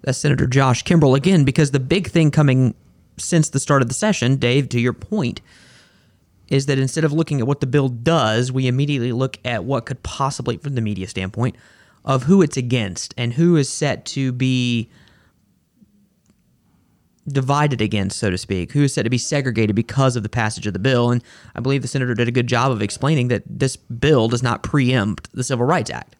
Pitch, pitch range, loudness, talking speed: 130 Hz, 120-145 Hz, -19 LUFS, 205 wpm